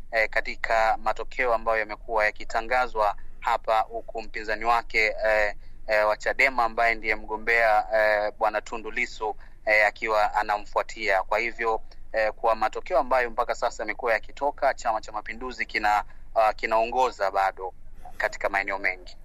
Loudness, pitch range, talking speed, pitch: -25 LUFS, 105-115 Hz, 135 wpm, 110 Hz